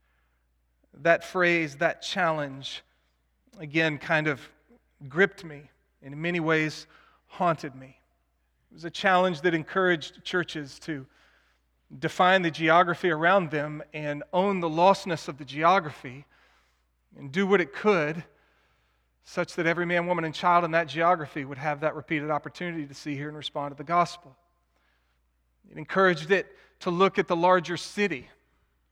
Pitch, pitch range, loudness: 155 Hz, 135-175 Hz, -26 LUFS